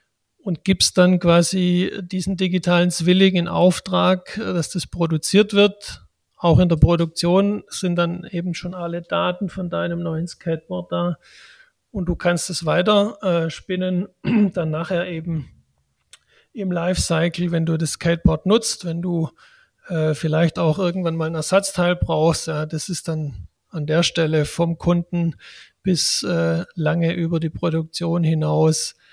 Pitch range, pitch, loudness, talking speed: 160-180 Hz, 170 Hz, -20 LUFS, 145 wpm